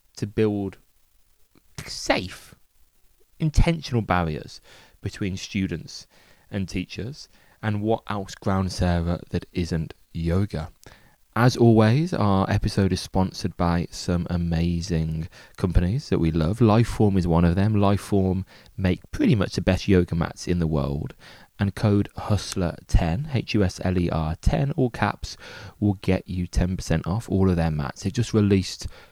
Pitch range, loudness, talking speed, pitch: 85-105 Hz, -24 LUFS, 145 wpm, 95 Hz